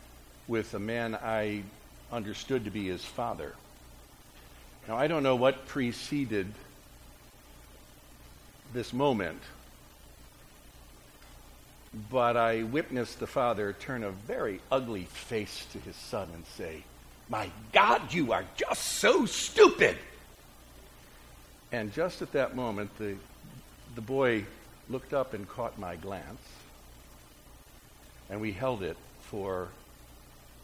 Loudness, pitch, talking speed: -31 LUFS, 75 Hz, 115 wpm